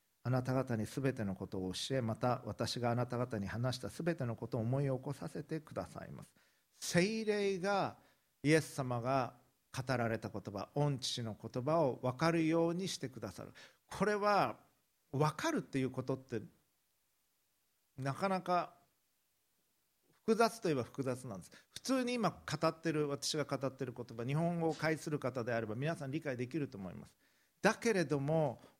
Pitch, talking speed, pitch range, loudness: 135 Hz, 320 characters per minute, 120-165 Hz, -37 LUFS